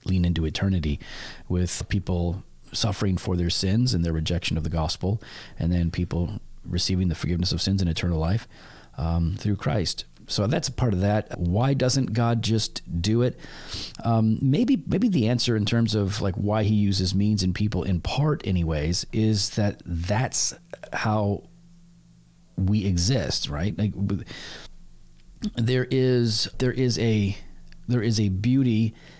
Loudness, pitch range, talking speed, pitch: -25 LUFS, 90-115 Hz, 155 wpm, 100 Hz